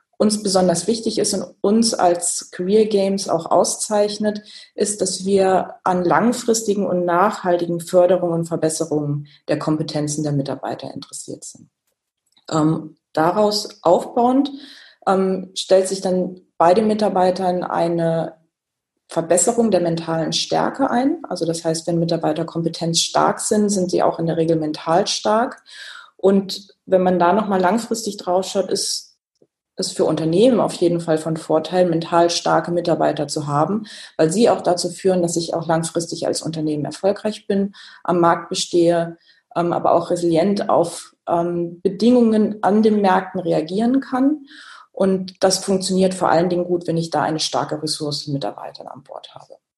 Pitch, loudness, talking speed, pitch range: 180 Hz, -19 LUFS, 150 wpm, 165-200 Hz